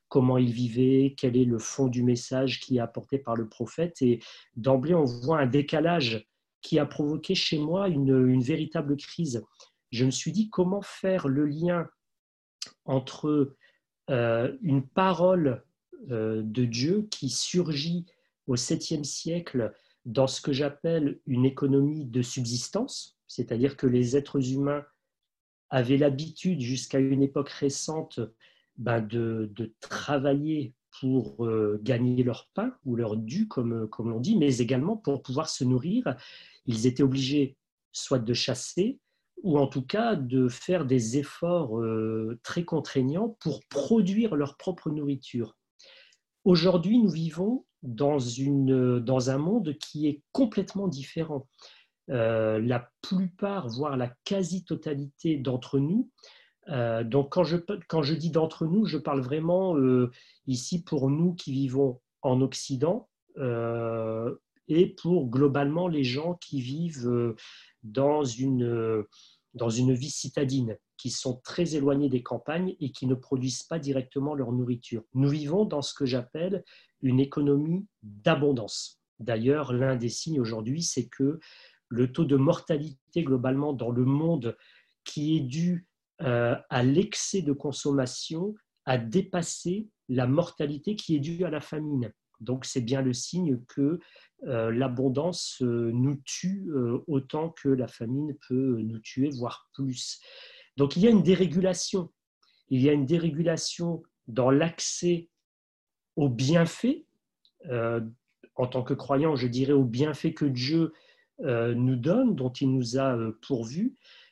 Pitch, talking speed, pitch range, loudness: 140 Hz, 145 wpm, 125-165 Hz, -28 LUFS